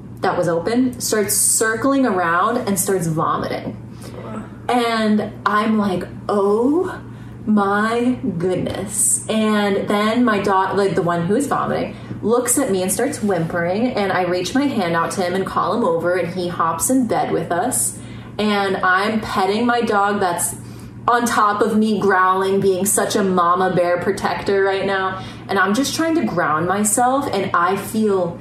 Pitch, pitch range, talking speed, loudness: 200 Hz, 185-230 Hz, 165 wpm, -18 LUFS